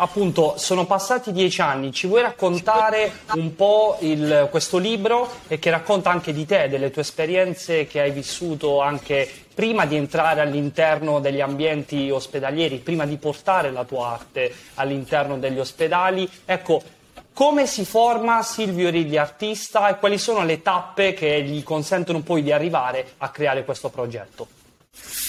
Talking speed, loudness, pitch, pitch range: 150 wpm, -21 LUFS, 160 Hz, 145-195 Hz